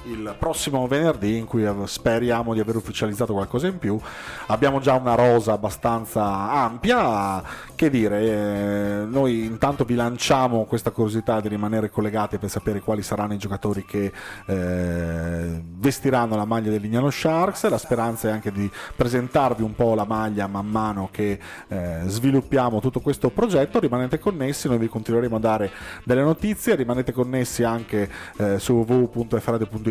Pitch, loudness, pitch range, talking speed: 115 Hz, -23 LUFS, 105-125 Hz, 155 wpm